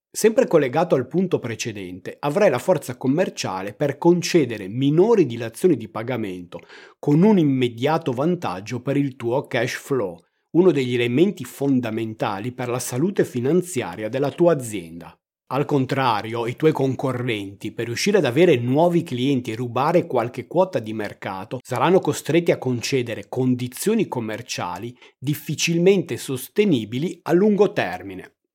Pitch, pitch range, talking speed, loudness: 130 Hz, 120-160 Hz, 130 wpm, -21 LUFS